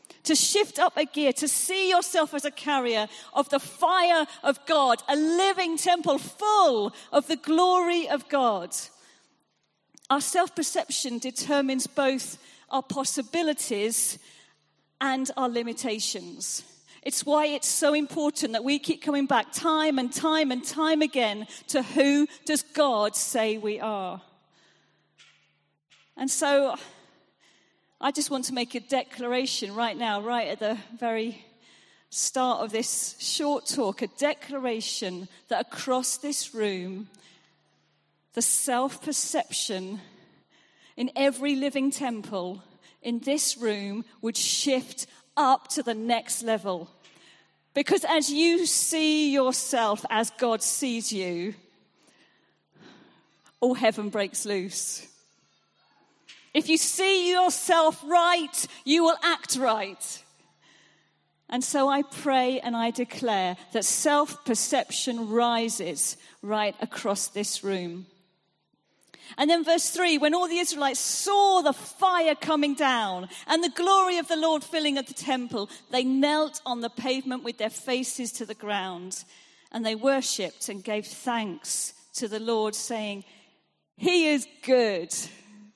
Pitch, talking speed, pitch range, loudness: 260 Hz, 130 wpm, 220-300 Hz, -26 LUFS